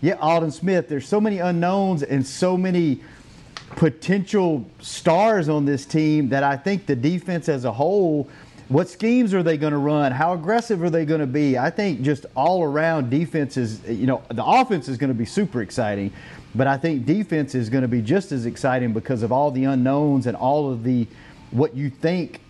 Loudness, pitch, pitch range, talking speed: -21 LUFS, 150 Hz, 130-170 Hz, 205 wpm